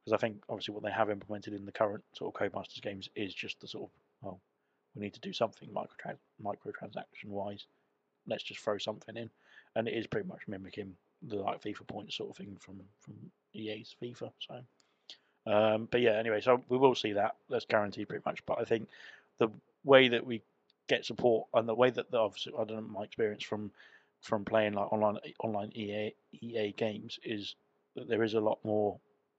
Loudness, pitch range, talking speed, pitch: -34 LUFS, 100-110 Hz, 205 wpm, 105 Hz